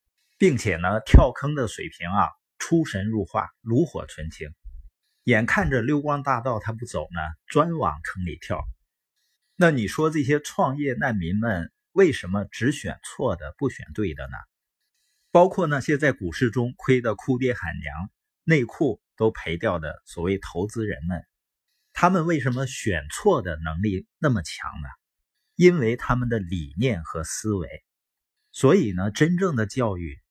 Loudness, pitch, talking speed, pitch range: -24 LUFS, 115 Hz, 225 characters per minute, 90-145 Hz